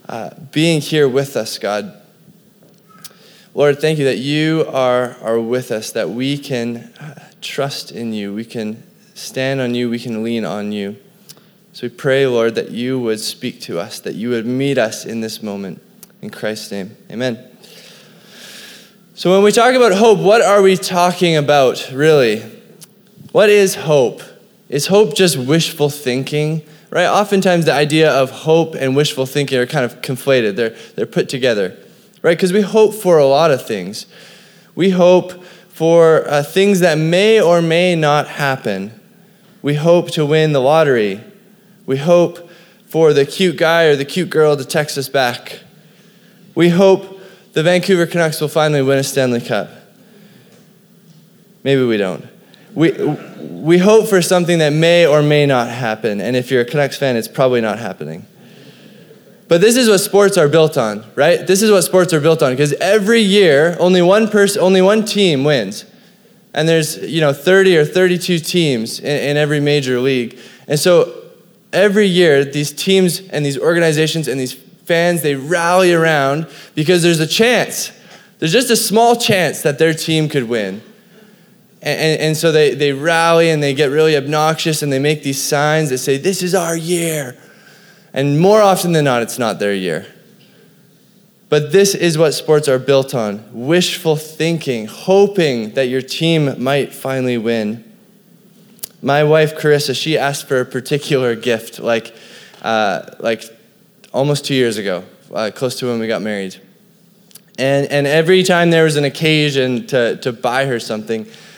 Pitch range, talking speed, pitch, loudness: 135-190 Hz, 170 wpm, 160 Hz, -14 LUFS